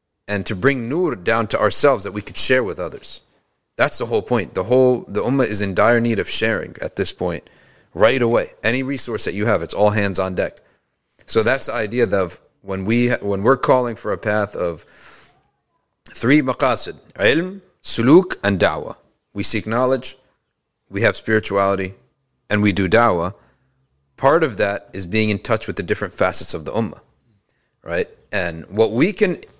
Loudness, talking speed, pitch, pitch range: -19 LUFS, 185 wpm, 110 Hz, 100-125 Hz